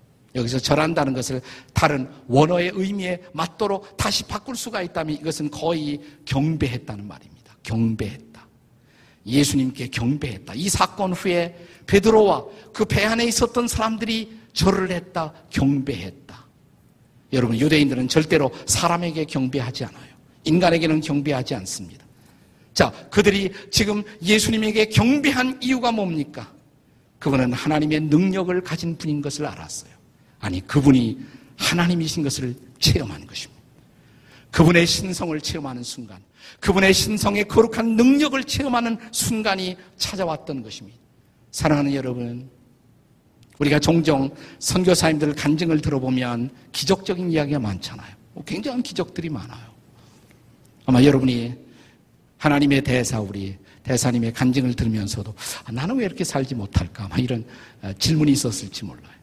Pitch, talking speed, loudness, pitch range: 145 Hz, 315 characters per minute, -21 LUFS, 125-180 Hz